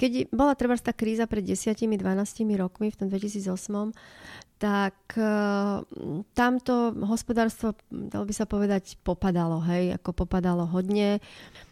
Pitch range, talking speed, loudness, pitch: 190-225 Hz, 115 wpm, -27 LUFS, 205 Hz